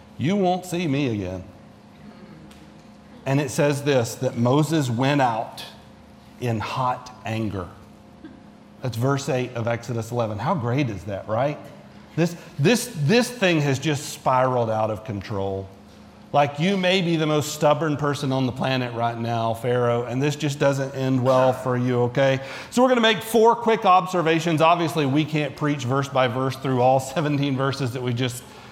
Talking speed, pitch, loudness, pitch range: 170 wpm, 135 Hz, -22 LUFS, 120-155 Hz